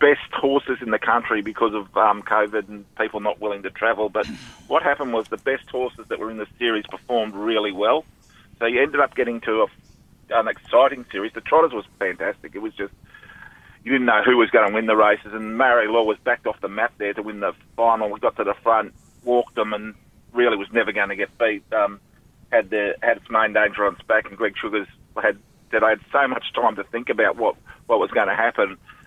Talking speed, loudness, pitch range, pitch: 235 wpm, -21 LUFS, 105-120 Hz, 110 Hz